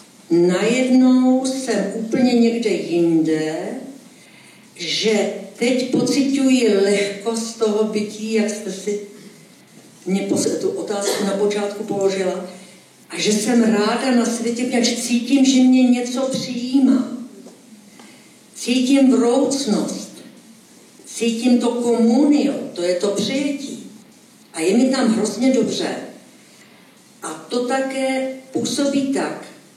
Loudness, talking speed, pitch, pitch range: -18 LUFS, 105 wpm, 240 Hz, 210-260 Hz